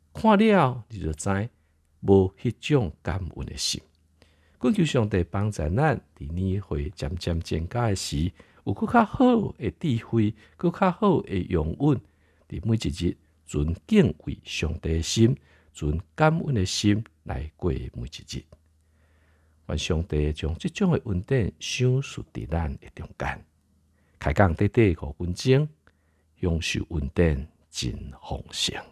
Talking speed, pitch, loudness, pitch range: 195 characters per minute, 90 Hz, -26 LUFS, 80-115 Hz